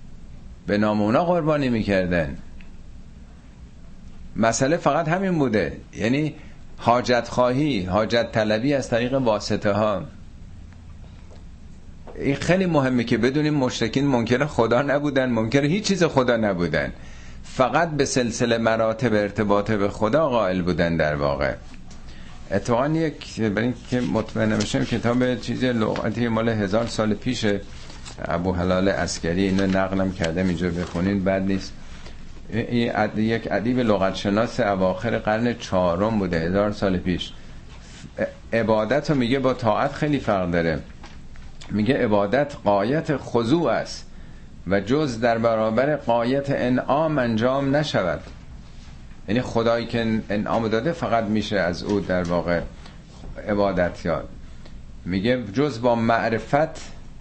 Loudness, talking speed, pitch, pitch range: -22 LUFS, 120 wpm, 110 Hz, 90-125 Hz